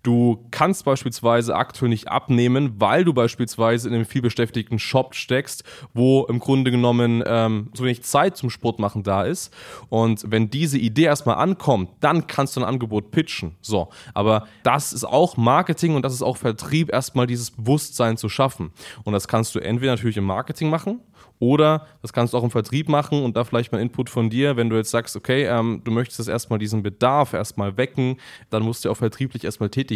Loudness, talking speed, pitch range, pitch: -21 LUFS, 205 wpm, 115-135 Hz, 120 Hz